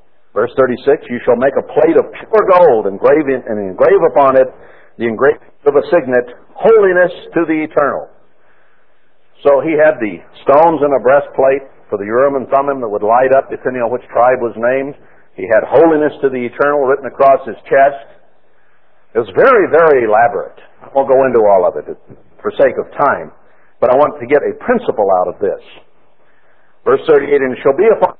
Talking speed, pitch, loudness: 190 wpm, 175 Hz, -12 LUFS